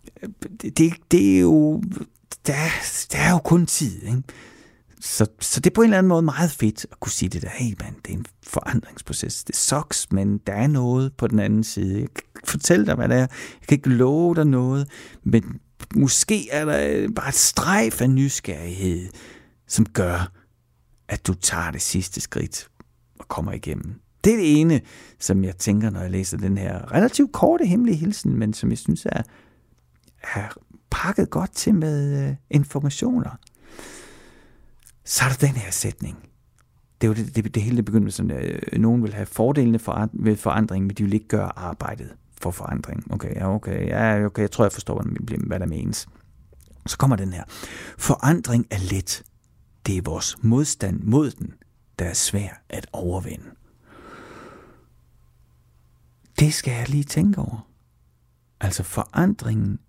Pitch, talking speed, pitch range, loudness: 110 Hz, 170 wpm, 95-140 Hz, -22 LUFS